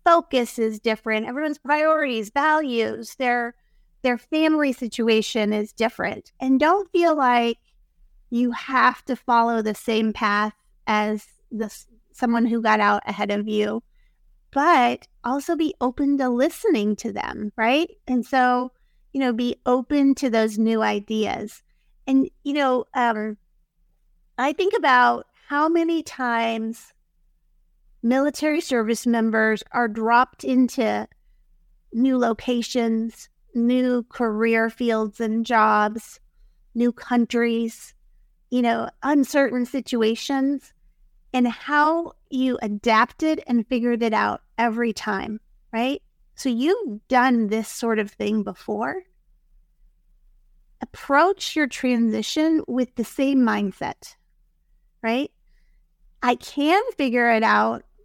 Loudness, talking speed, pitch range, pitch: -22 LUFS, 115 wpm, 225-270 Hz, 240 Hz